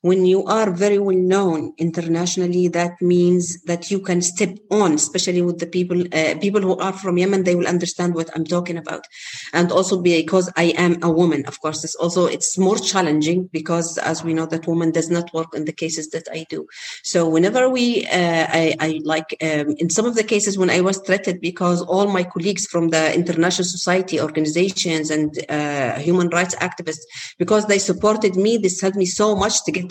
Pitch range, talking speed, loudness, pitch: 165-190 Hz, 205 wpm, -19 LUFS, 175 Hz